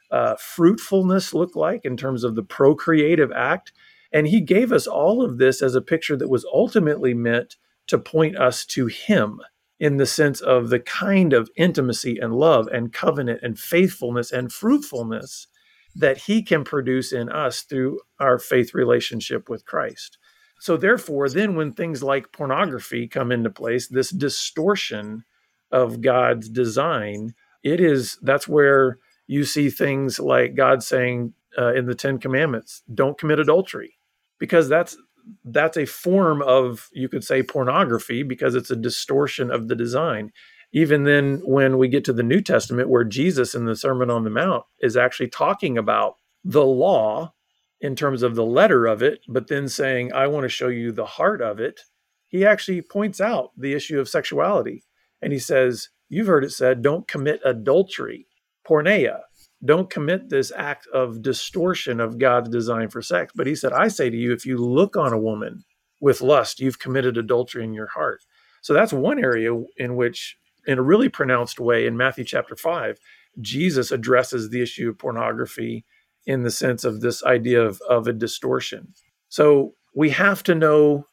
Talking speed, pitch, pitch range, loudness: 175 wpm, 135 Hz, 120-160 Hz, -21 LUFS